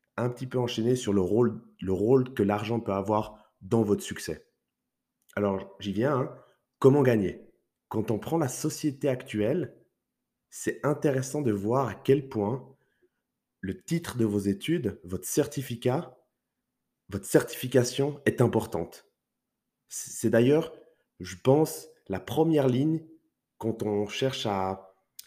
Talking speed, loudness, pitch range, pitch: 135 wpm, -28 LUFS, 105-140 Hz, 120 Hz